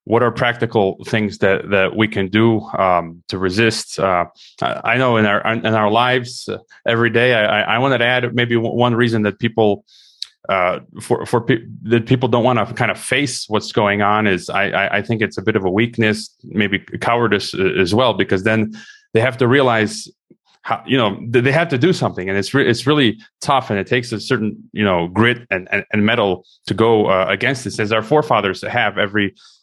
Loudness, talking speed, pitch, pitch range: -17 LUFS, 210 wpm, 110 Hz, 105-120 Hz